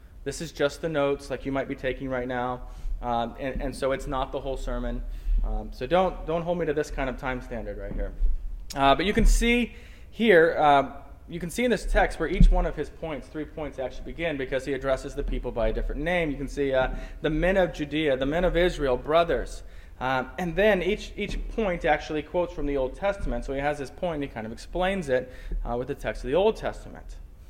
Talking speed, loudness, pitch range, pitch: 240 wpm, -27 LUFS, 125-170 Hz, 140 Hz